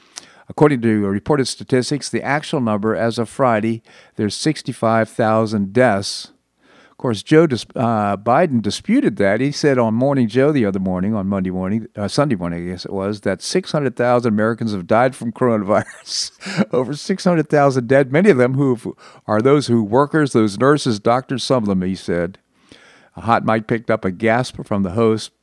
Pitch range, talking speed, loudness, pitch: 105-135 Hz, 175 wpm, -18 LUFS, 115 Hz